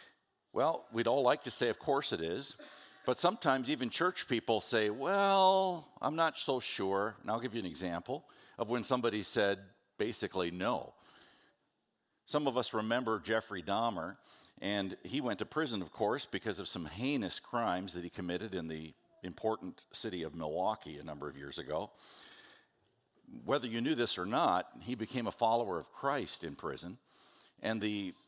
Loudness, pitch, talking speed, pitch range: -35 LUFS, 110 Hz, 170 wpm, 95-130 Hz